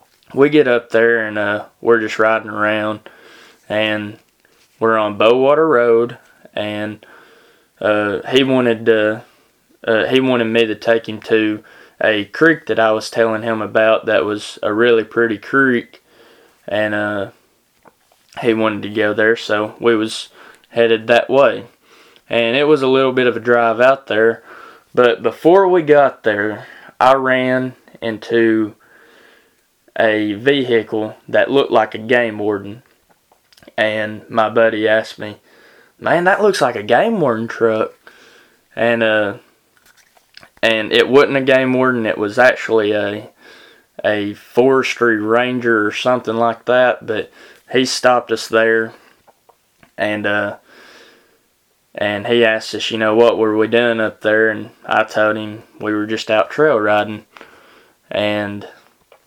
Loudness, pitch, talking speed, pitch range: -15 LUFS, 110 Hz, 145 wpm, 105-120 Hz